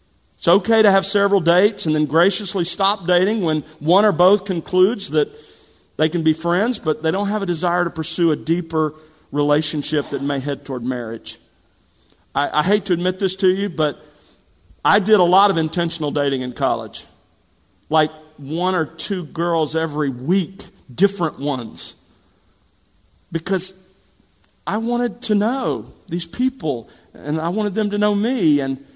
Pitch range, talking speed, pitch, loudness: 145-195 Hz, 165 wpm, 165 Hz, -19 LUFS